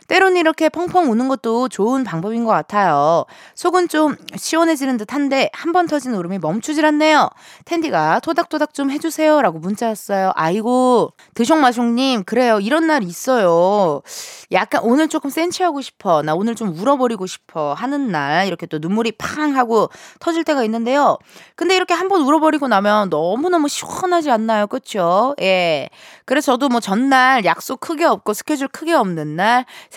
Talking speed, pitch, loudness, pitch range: 350 characters per minute, 260 Hz, -17 LUFS, 210-315 Hz